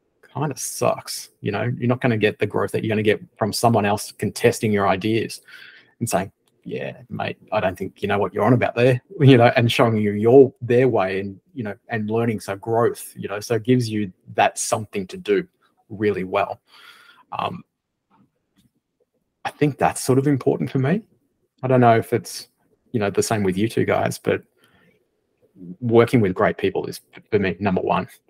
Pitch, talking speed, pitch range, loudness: 115 Hz, 205 wpm, 105-130 Hz, -21 LUFS